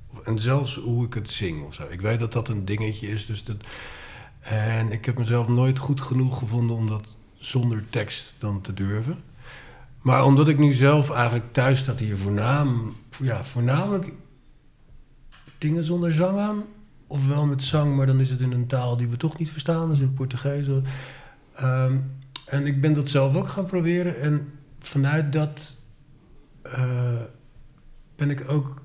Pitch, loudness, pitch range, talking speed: 130 Hz, -24 LUFS, 120-145 Hz, 175 wpm